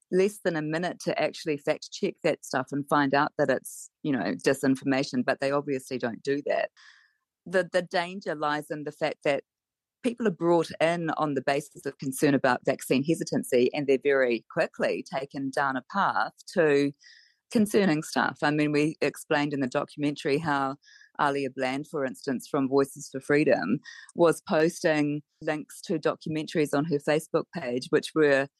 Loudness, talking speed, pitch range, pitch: -27 LUFS, 170 wpm, 140-165 Hz, 150 Hz